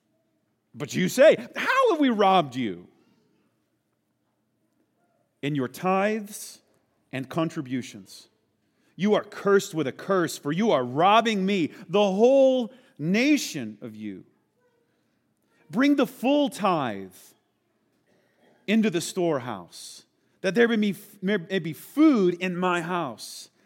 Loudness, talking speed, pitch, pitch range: -24 LUFS, 120 wpm, 190 Hz, 145-220 Hz